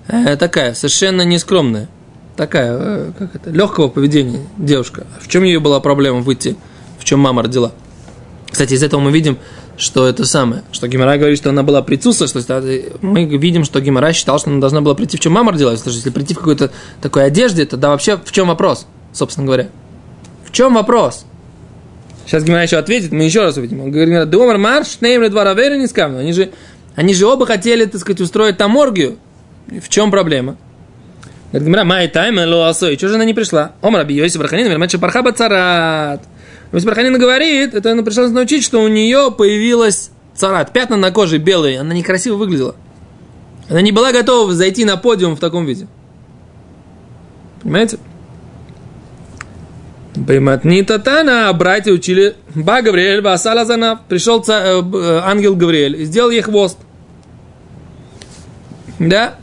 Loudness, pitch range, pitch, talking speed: -12 LUFS, 145-215 Hz, 180 Hz, 150 wpm